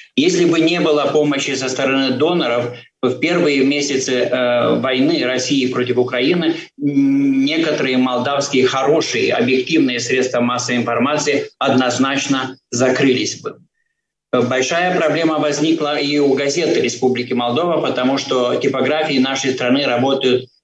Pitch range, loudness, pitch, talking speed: 125-150 Hz, -16 LUFS, 135 Hz, 115 wpm